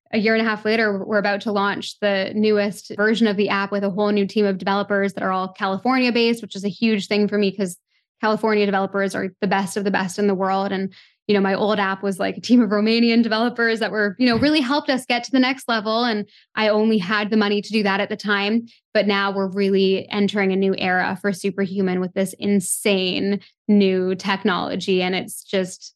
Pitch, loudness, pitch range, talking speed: 205 Hz, -20 LUFS, 195-220 Hz, 235 wpm